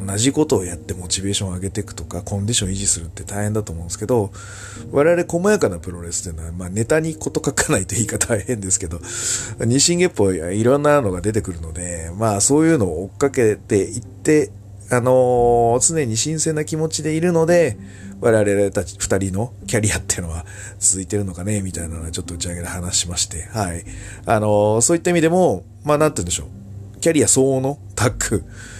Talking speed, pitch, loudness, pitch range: 450 characters per minute, 105 Hz, -19 LUFS, 95-125 Hz